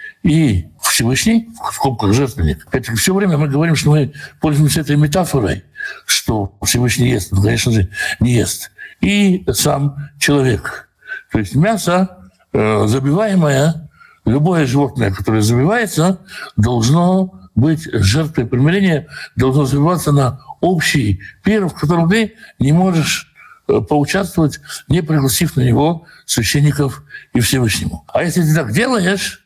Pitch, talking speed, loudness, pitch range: 145 Hz, 125 wpm, -15 LUFS, 120-175 Hz